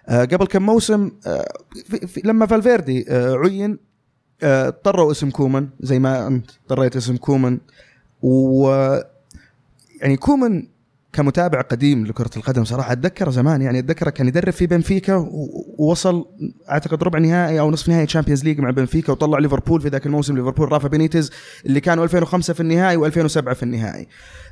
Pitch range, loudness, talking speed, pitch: 130-170 Hz, -18 LUFS, 145 wpm, 145 Hz